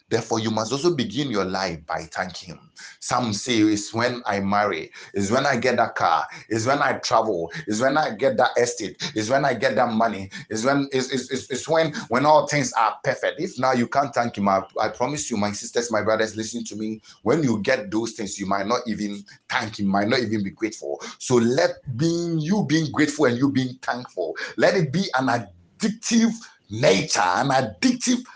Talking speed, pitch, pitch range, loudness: 215 wpm, 120 Hz, 105-140 Hz, -23 LUFS